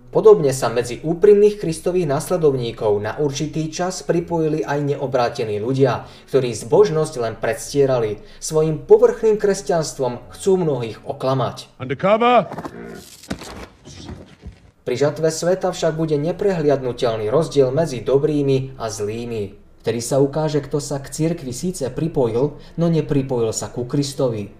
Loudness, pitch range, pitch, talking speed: -19 LUFS, 125-165 Hz, 145 Hz, 115 wpm